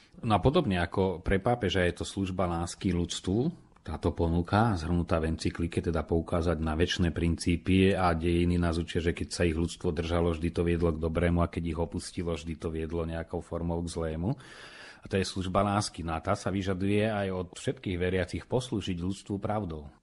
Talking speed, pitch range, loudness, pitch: 190 wpm, 85-95 Hz, -30 LUFS, 85 Hz